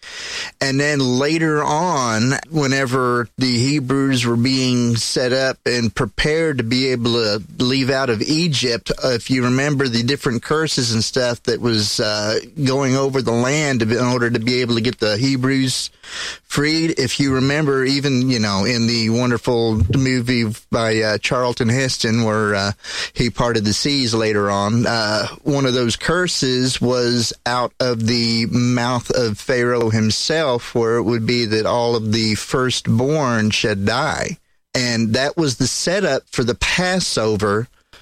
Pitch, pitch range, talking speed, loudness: 125 Hz, 115-135 Hz, 160 wpm, -18 LUFS